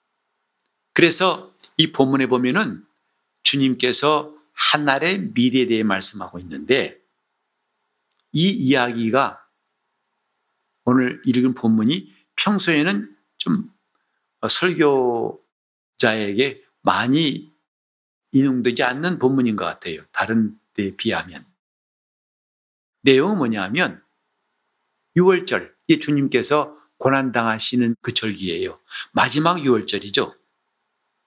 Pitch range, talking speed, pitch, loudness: 110-150 Hz, 205 characters per minute, 130 Hz, -19 LUFS